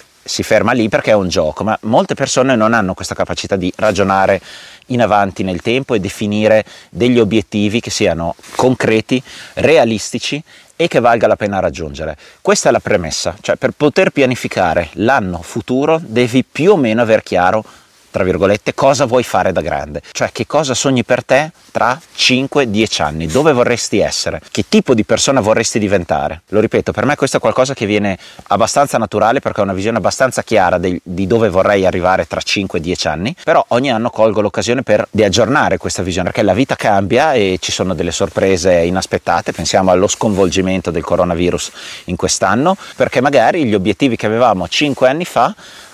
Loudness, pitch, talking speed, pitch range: -14 LUFS, 110 Hz, 180 wpm, 95-130 Hz